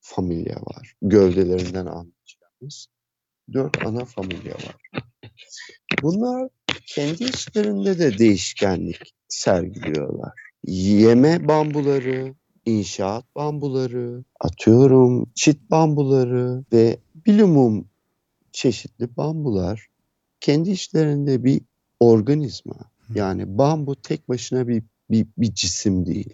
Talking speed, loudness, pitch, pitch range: 85 wpm, -20 LUFS, 125 Hz, 110-145 Hz